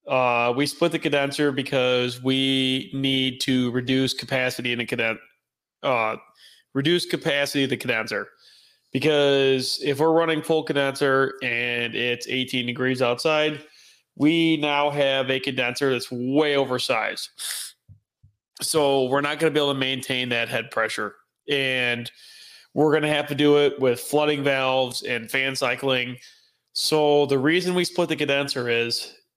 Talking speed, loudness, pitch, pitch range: 145 wpm, -23 LUFS, 135 Hz, 125-145 Hz